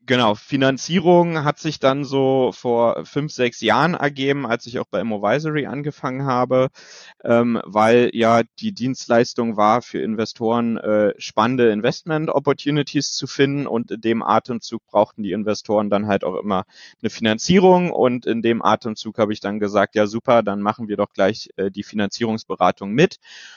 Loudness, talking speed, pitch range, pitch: -19 LUFS, 165 wpm, 110-140 Hz, 120 Hz